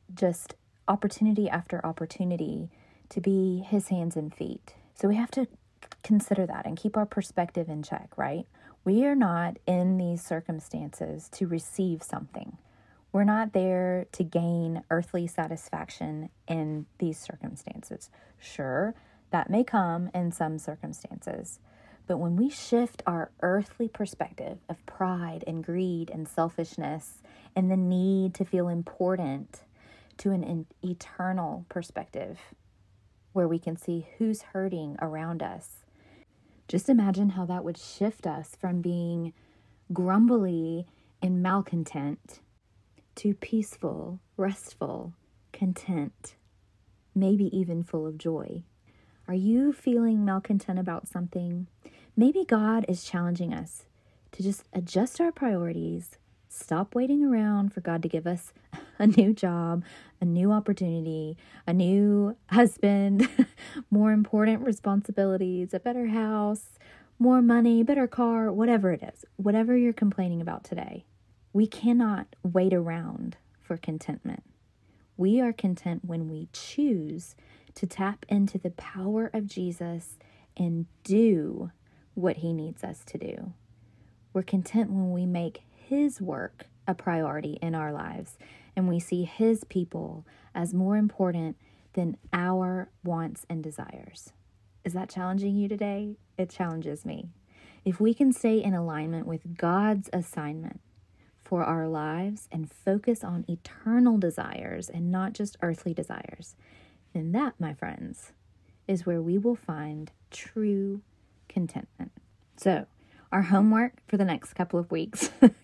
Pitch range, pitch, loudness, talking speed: 165-205 Hz, 180 Hz, -28 LUFS, 130 wpm